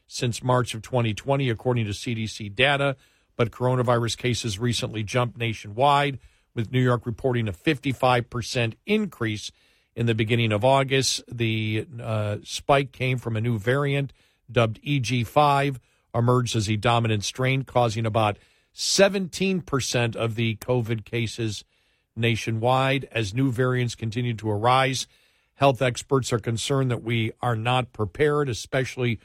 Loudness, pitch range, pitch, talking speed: -24 LUFS, 115-130 Hz, 120 Hz, 135 wpm